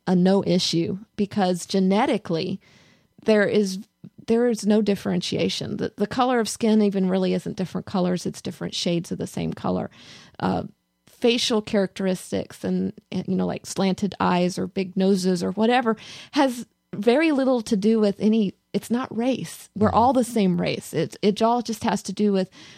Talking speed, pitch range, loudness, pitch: 170 wpm, 185-225 Hz, -23 LUFS, 200 Hz